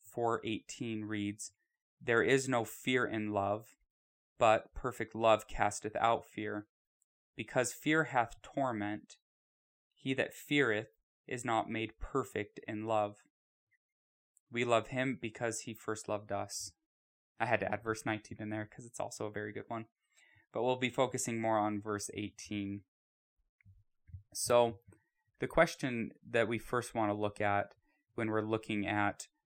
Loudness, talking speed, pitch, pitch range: -35 LUFS, 150 wpm, 110 Hz, 105-120 Hz